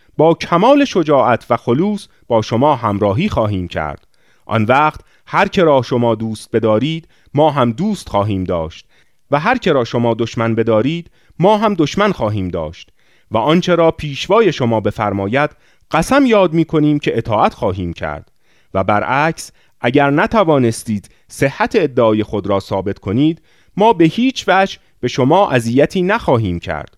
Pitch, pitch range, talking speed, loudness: 125 Hz, 110-165 Hz, 150 wpm, -15 LUFS